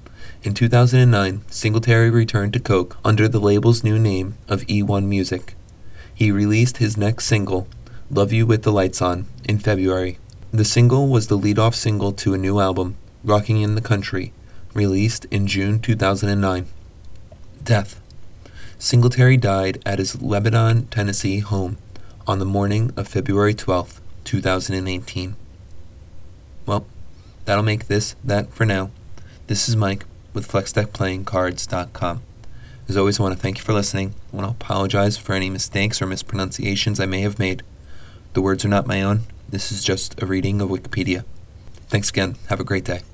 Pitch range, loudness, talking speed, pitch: 95-110 Hz, -20 LUFS, 160 wpm, 100 Hz